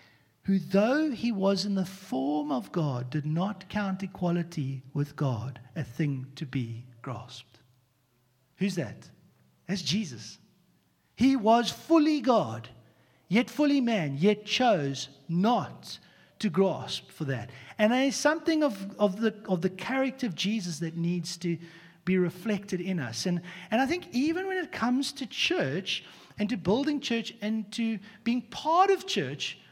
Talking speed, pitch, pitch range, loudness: 155 wpm, 190 Hz, 150-230 Hz, -29 LUFS